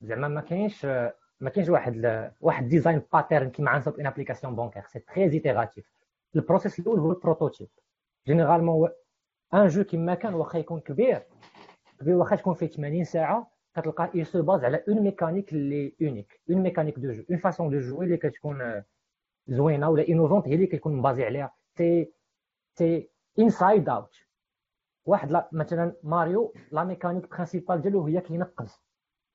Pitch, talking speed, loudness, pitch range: 165 Hz, 155 wpm, -26 LUFS, 145-180 Hz